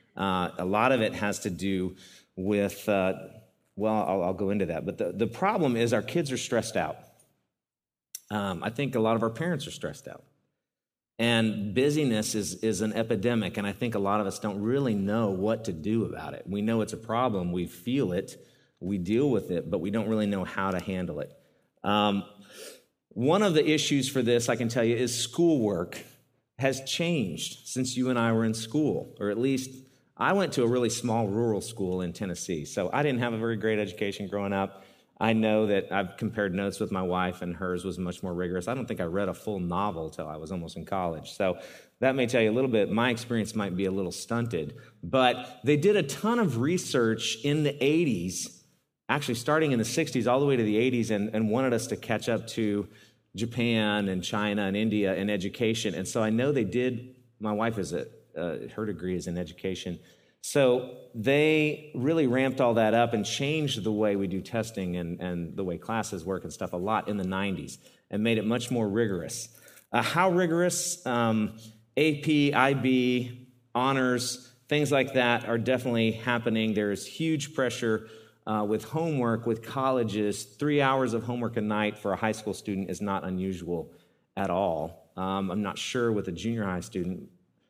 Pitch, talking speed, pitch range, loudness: 110 Hz, 205 wpm, 100-125 Hz, -28 LUFS